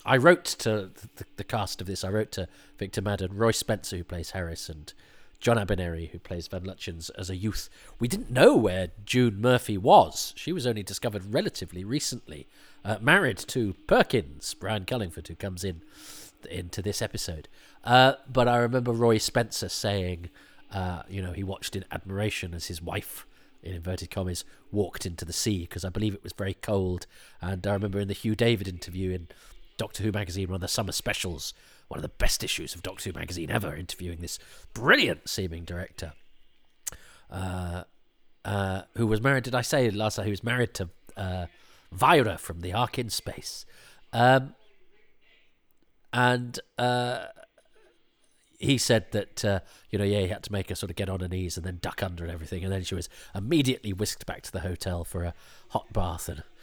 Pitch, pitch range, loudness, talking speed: 95 Hz, 90-110 Hz, -28 LUFS, 190 wpm